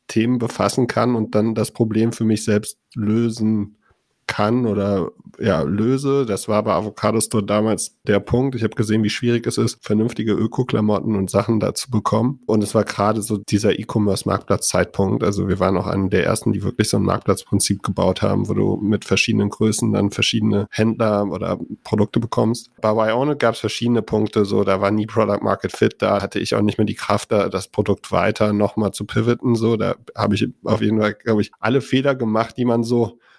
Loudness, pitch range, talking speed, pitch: -19 LUFS, 105-115 Hz, 200 wpm, 110 Hz